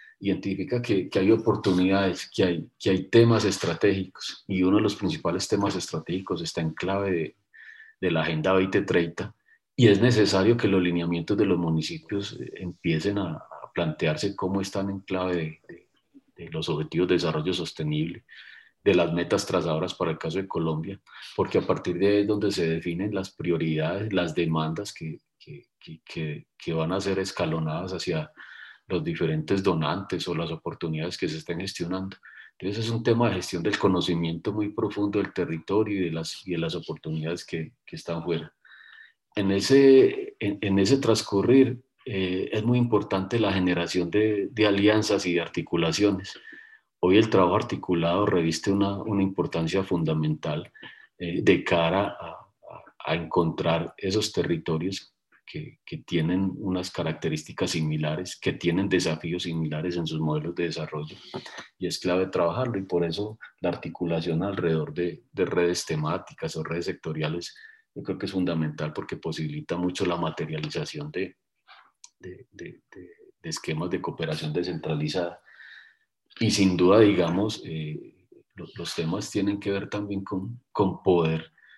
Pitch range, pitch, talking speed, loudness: 85-105 Hz, 95 Hz, 160 wpm, -26 LUFS